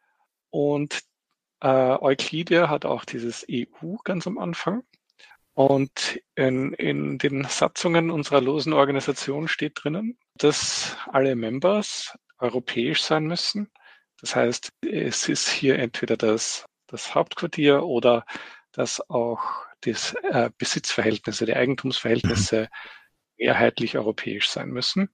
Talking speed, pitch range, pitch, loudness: 110 wpm, 125-170 Hz, 140 Hz, -24 LUFS